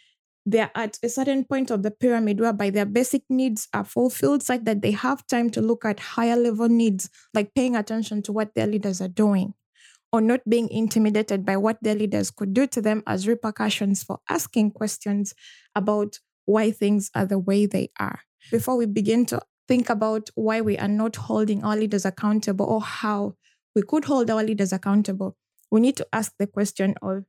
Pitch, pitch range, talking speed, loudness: 215 Hz, 205-230 Hz, 200 wpm, -24 LUFS